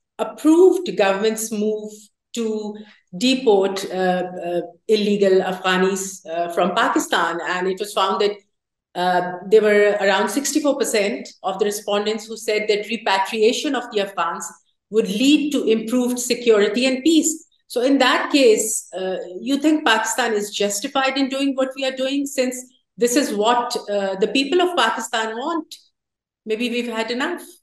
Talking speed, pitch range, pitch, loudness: 150 wpm, 200-260 Hz, 220 Hz, -19 LUFS